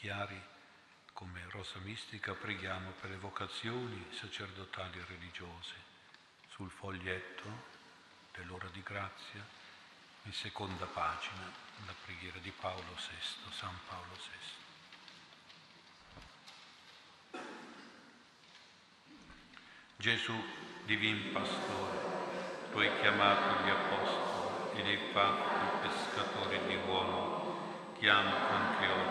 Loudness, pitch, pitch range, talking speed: -37 LUFS, 95 Hz, 90-100 Hz, 95 wpm